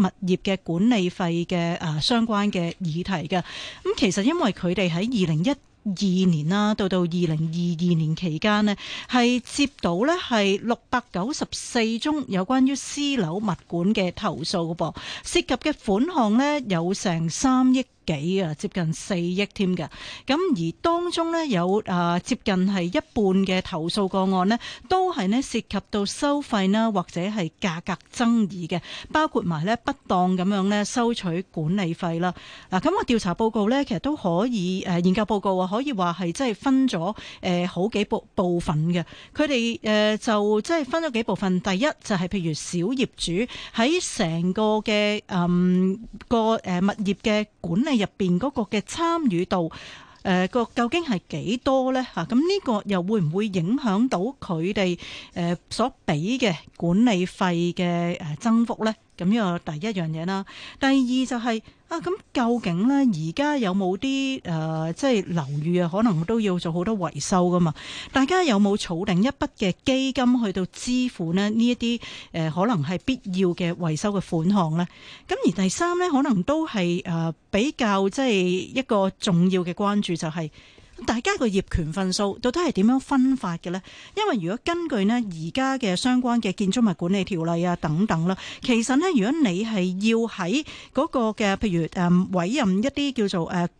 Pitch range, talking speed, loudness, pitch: 180-240 Hz, 260 characters per minute, -24 LUFS, 200 Hz